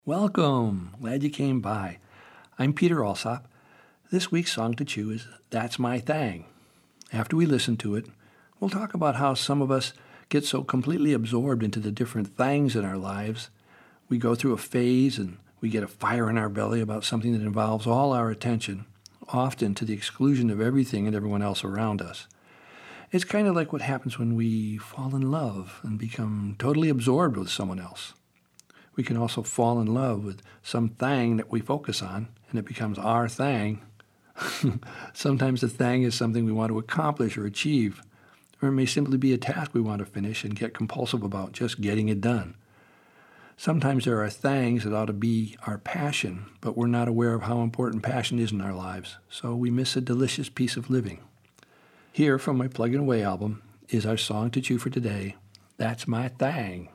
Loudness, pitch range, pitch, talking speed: -27 LUFS, 105-130 Hz, 115 Hz, 195 wpm